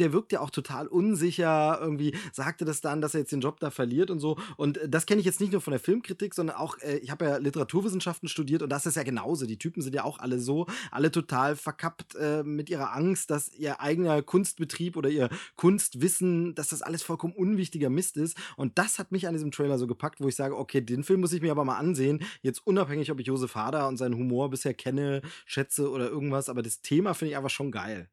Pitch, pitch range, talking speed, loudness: 150 Hz, 140-175 Hz, 240 wpm, -29 LUFS